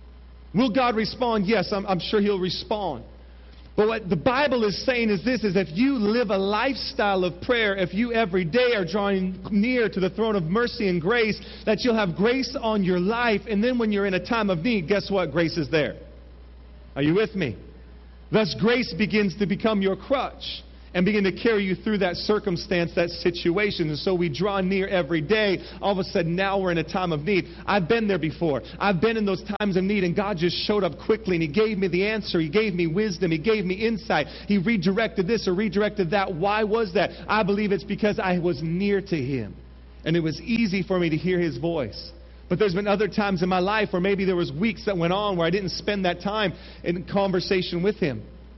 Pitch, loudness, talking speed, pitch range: 195 Hz, -24 LUFS, 225 wpm, 175-215 Hz